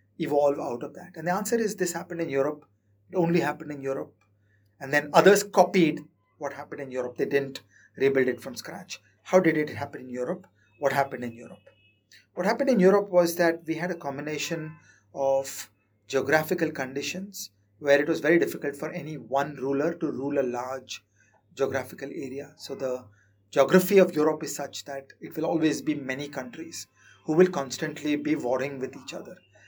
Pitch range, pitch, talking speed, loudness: 130-165 Hz, 145 Hz, 185 wpm, -26 LUFS